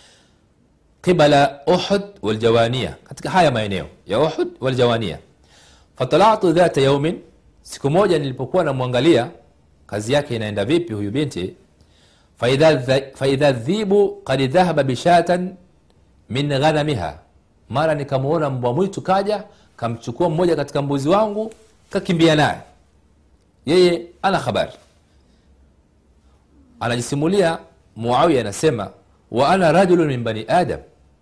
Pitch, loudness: 140 Hz, -18 LUFS